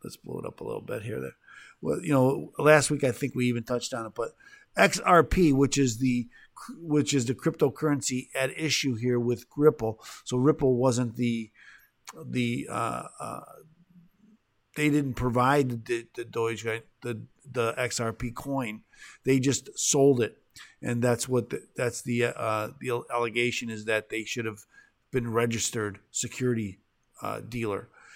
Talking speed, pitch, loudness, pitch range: 160 wpm, 125 Hz, -27 LUFS, 115-140 Hz